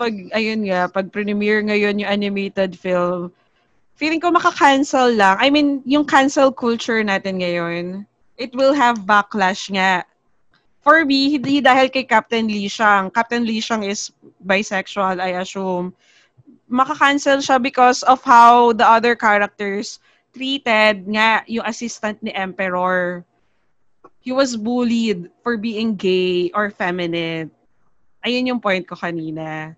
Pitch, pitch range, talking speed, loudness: 215 Hz, 190-250 Hz, 135 wpm, -17 LUFS